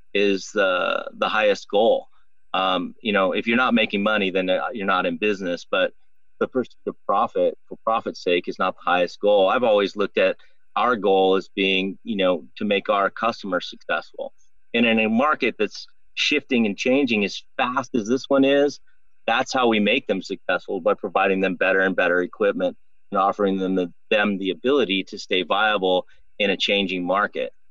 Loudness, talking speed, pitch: -22 LUFS, 185 wpm, 105 Hz